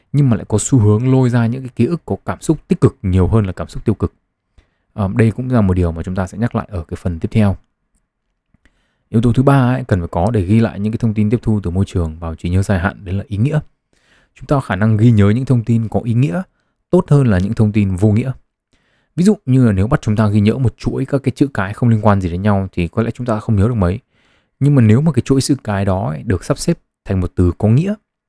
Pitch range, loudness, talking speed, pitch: 100-125 Hz, -16 LUFS, 295 wpm, 110 Hz